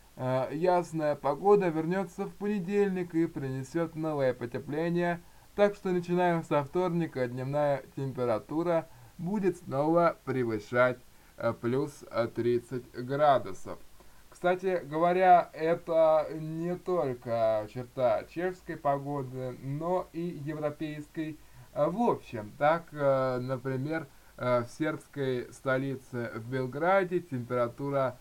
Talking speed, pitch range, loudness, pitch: 90 wpm, 130-170 Hz, -30 LUFS, 150 Hz